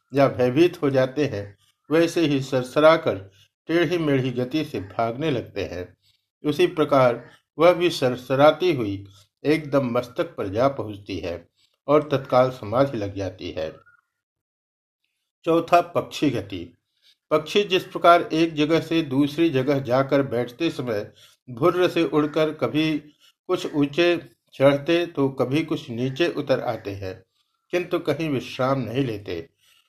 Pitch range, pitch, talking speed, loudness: 125-165 Hz, 140 Hz, 130 wpm, -22 LUFS